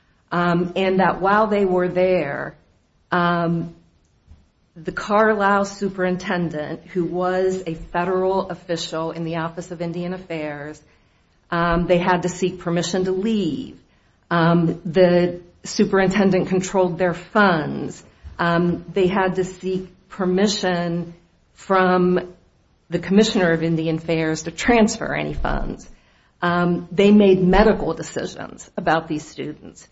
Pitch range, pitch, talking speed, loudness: 165-185 Hz, 175 Hz, 120 wpm, -20 LUFS